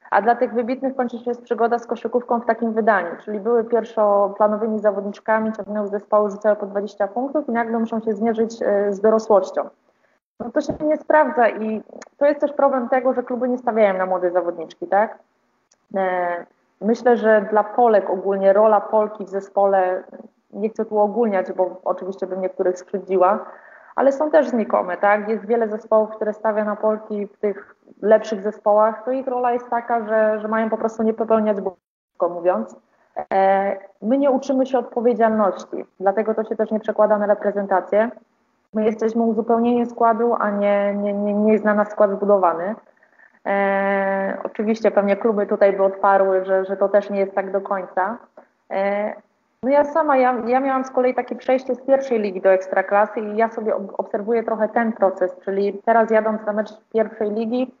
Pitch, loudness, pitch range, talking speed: 215 Hz, -20 LUFS, 200-235 Hz, 180 wpm